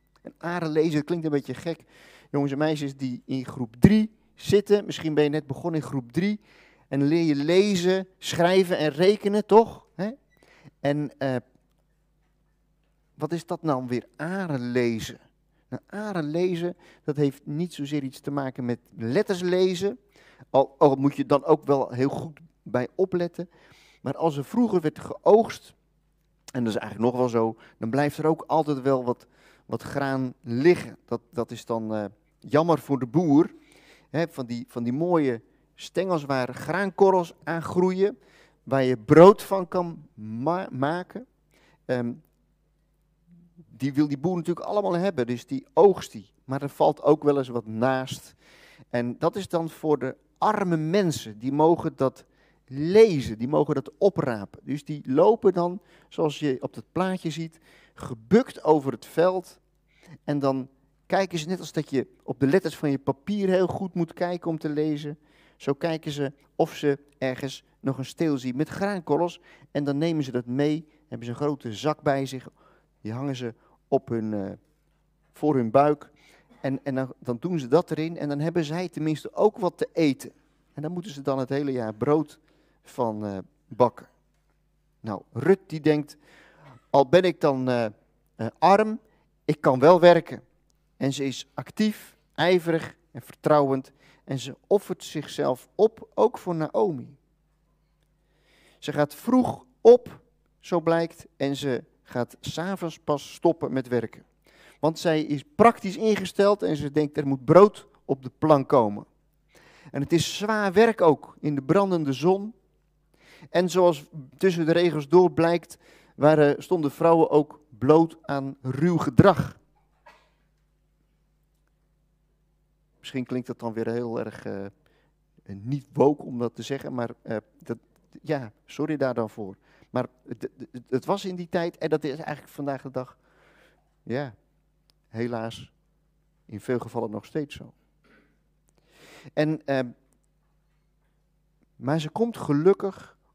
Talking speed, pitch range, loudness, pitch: 160 wpm, 135-170 Hz, -25 LUFS, 150 Hz